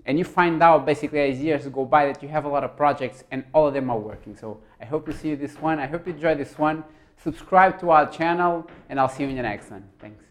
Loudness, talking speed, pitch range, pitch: -22 LUFS, 280 wpm, 130-160 Hz, 150 Hz